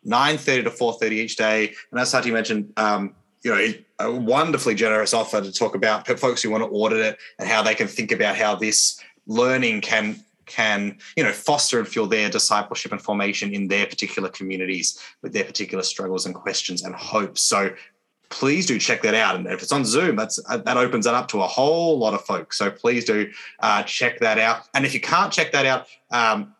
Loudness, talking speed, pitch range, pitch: -21 LUFS, 220 wpm, 100-125 Hz, 110 Hz